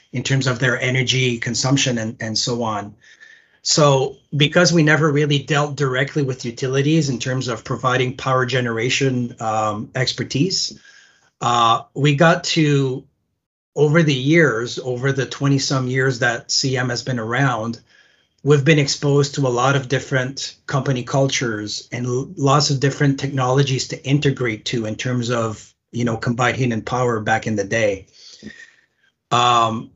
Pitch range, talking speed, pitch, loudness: 120-145 Hz, 145 wpm, 130 Hz, -19 LUFS